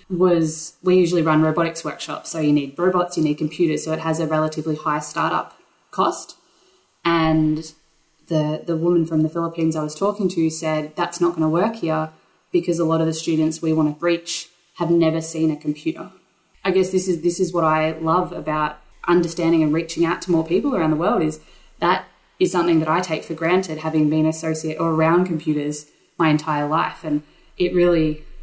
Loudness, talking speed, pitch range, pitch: -20 LUFS, 200 wpm, 155-170 Hz, 160 Hz